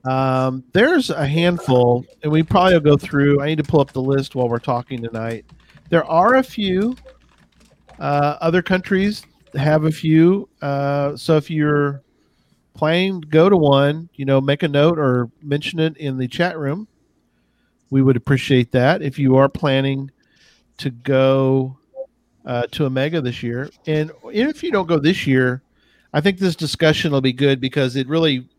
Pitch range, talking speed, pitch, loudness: 135-165 Hz, 175 wpm, 145 Hz, -18 LUFS